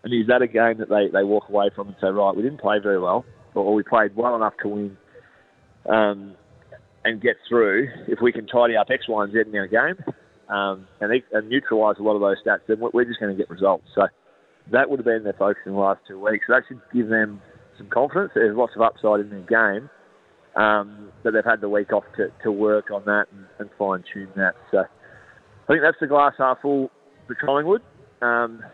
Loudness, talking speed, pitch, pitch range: -21 LUFS, 235 wpm, 105 Hz, 100-115 Hz